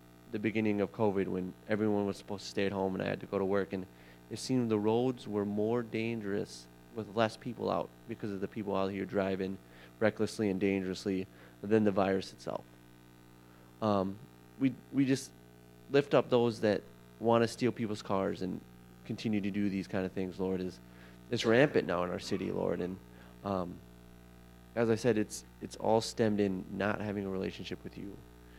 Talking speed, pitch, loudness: 190 wpm, 95 Hz, -33 LUFS